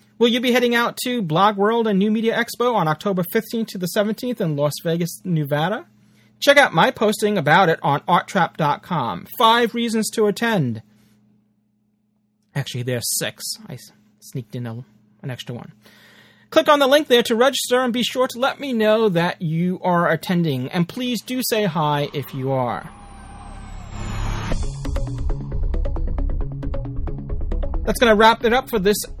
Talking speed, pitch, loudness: 160 wpm, 170 Hz, -20 LUFS